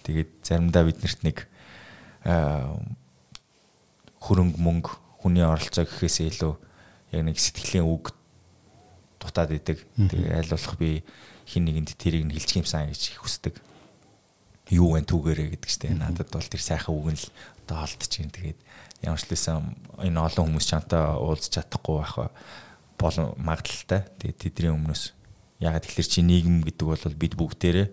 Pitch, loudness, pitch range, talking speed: 85 Hz, -26 LUFS, 80-90 Hz, 140 wpm